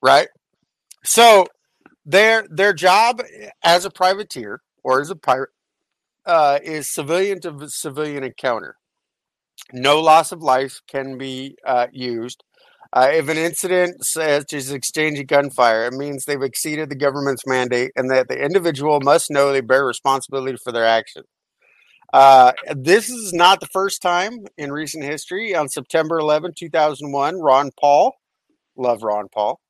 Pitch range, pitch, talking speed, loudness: 135-170 Hz, 145 Hz, 150 wpm, -17 LUFS